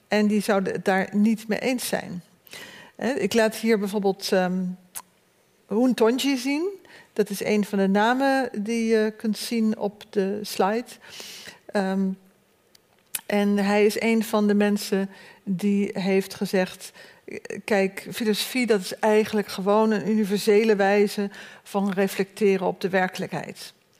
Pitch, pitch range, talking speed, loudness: 205 Hz, 195-220 Hz, 140 wpm, -24 LUFS